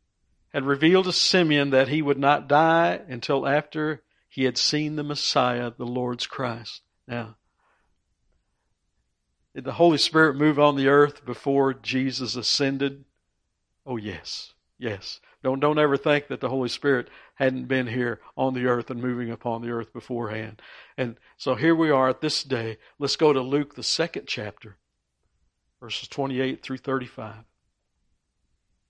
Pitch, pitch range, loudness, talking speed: 130 Hz, 120-145 Hz, -24 LUFS, 155 wpm